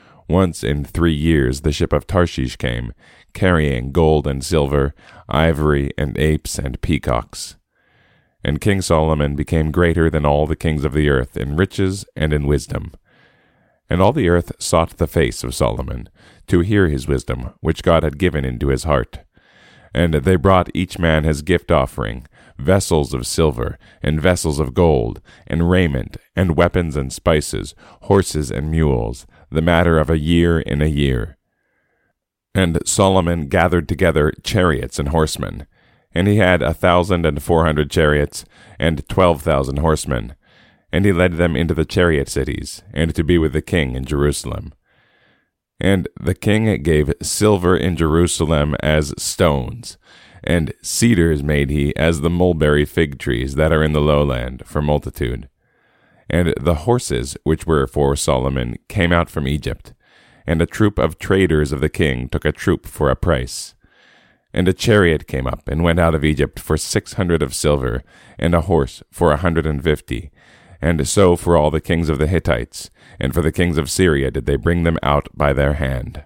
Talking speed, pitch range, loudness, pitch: 170 wpm, 75-85 Hz, -18 LUFS, 80 Hz